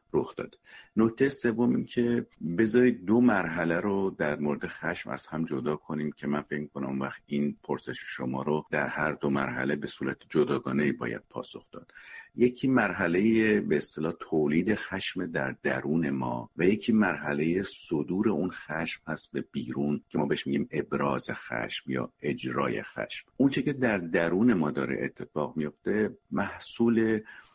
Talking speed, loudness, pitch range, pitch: 155 wpm, -29 LUFS, 70-115 Hz, 75 Hz